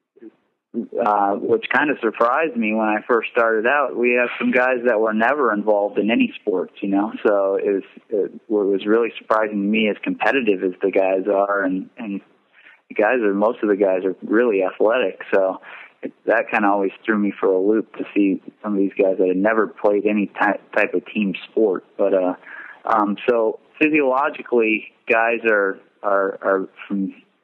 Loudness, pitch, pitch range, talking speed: -20 LUFS, 105 Hz, 100-115 Hz, 190 wpm